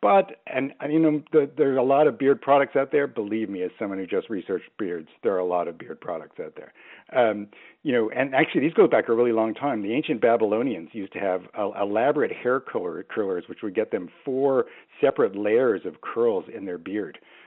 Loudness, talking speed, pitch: -24 LUFS, 230 wpm, 145 Hz